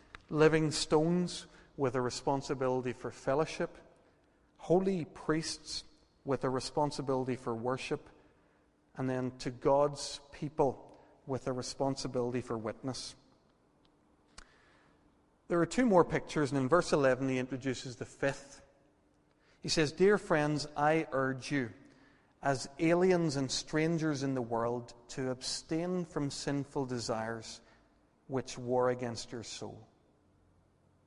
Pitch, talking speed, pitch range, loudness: 135 Hz, 120 wpm, 125-155 Hz, -33 LUFS